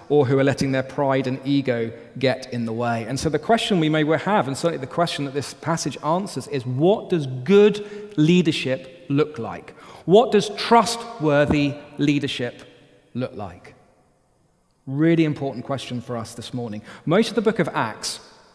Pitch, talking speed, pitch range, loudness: 145 Hz, 170 wpm, 130-175 Hz, -22 LUFS